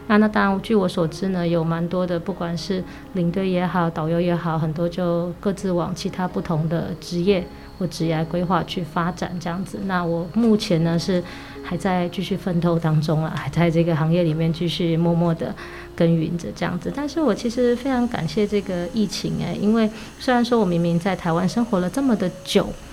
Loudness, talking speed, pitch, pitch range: -22 LUFS, 305 characters per minute, 175 Hz, 170-195 Hz